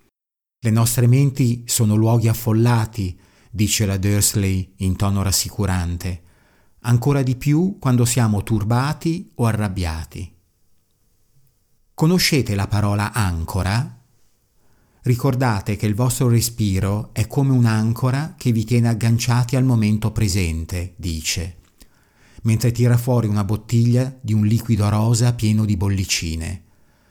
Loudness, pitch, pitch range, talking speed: -19 LUFS, 110 Hz, 100-120 Hz, 115 wpm